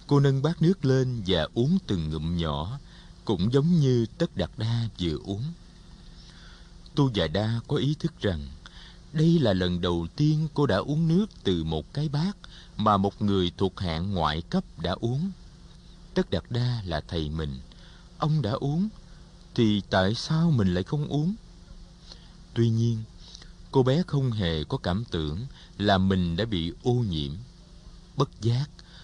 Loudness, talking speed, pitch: -27 LUFS, 165 wpm, 115 Hz